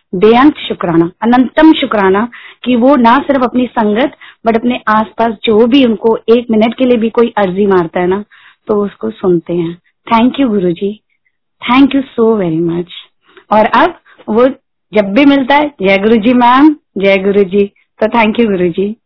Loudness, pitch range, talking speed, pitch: -10 LUFS, 200-250 Hz, 185 wpm, 225 Hz